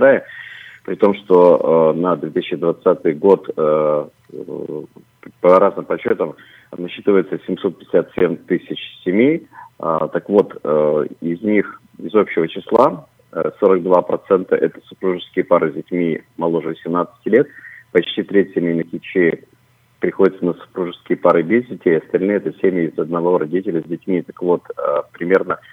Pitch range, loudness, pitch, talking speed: 85-95 Hz, -17 LUFS, 90 Hz, 130 wpm